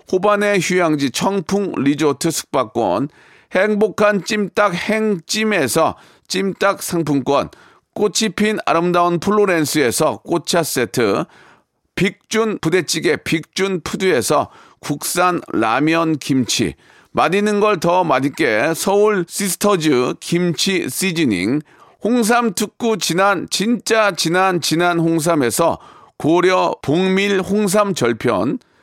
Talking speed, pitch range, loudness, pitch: 220 characters per minute, 165-205 Hz, -17 LUFS, 185 Hz